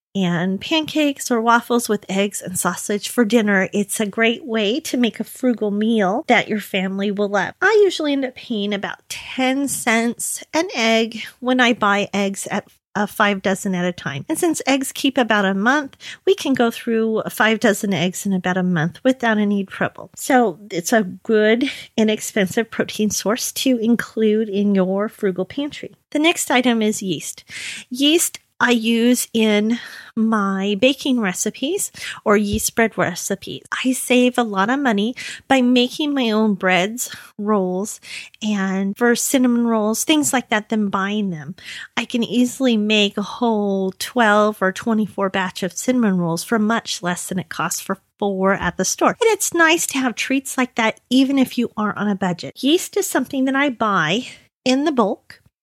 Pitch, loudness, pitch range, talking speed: 220 Hz, -19 LUFS, 200-250 Hz, 180 wpm